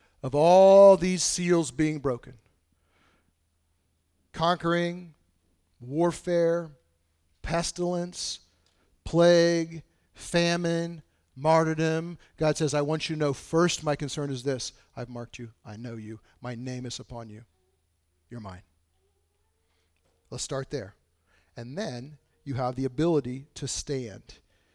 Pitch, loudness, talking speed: 125 Hz, -26 LUFS, 115 wpm